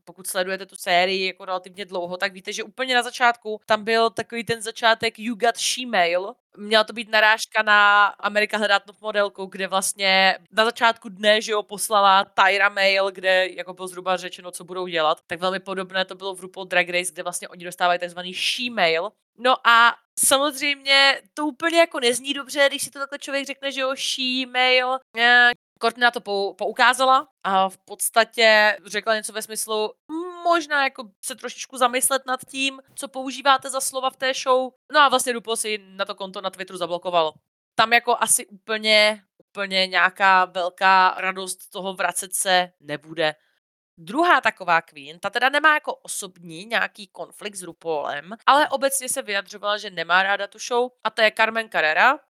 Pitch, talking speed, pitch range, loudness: 210 Hz, 180 wpm, 190-245 Hz, -21 LUFS